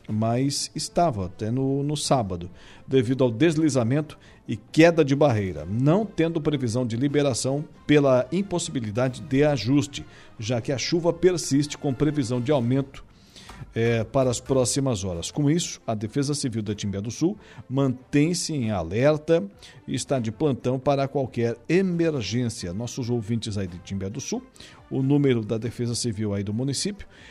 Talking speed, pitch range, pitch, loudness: 155 wpm, 115-150 Hz, 135 Hz, -24 LUFS